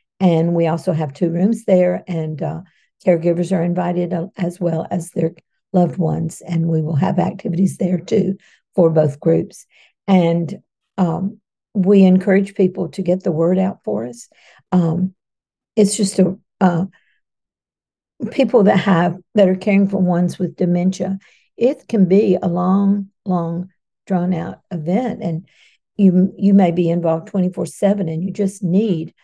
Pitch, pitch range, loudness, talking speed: 180 Hz, 170-195 Hz, -18 LUFS, 155 wpm